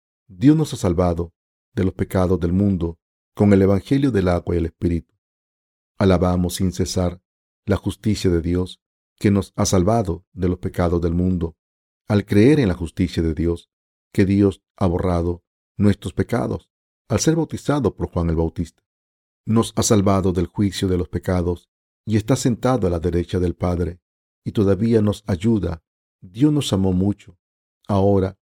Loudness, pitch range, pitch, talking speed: -20 LUFS, 85-100 Hz, 95 Hz, 165 wpm